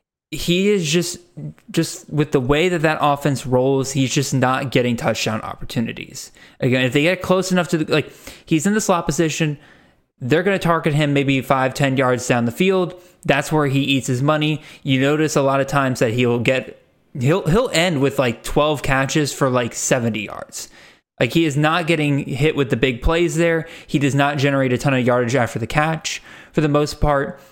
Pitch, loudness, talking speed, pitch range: 145 Hz, -19 LUFS, 205 wpm, 135-165 Hz